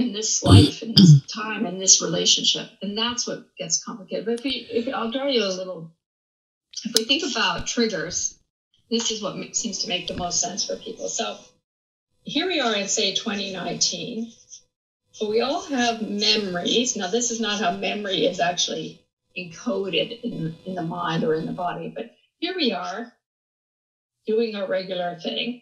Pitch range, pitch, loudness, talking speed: 185-235 Hz, 220 Hz, -22 LUFS, 180 wpm